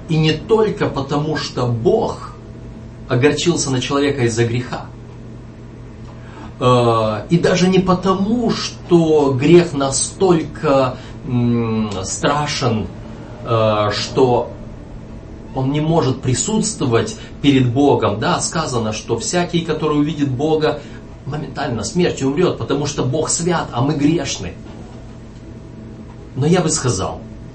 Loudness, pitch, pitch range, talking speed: -17 LUFS, 130 Hz, 115-150 Hz, 100 wpm